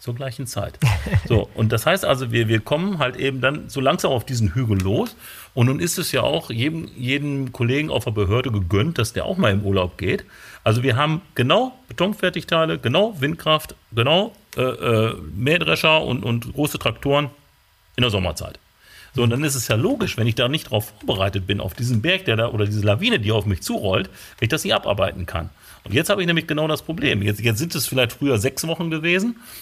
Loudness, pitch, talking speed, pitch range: -21 LUFS, 125 Hz, 215 wpm, 110-155 Hz